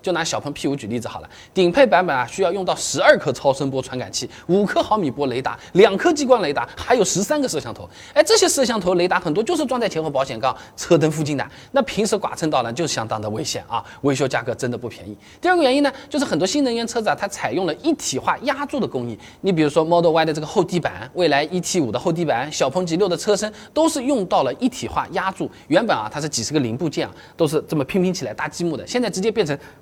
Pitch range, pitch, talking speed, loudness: 140-230 Hz, 170 Hz, 390 characters per minute, -20 LUFS